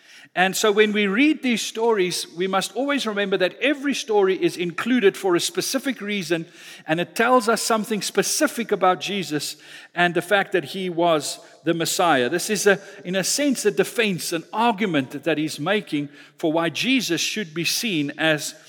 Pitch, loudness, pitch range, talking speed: 195 Hz, -22 LUFS, 170-230 Hz, 180 wpm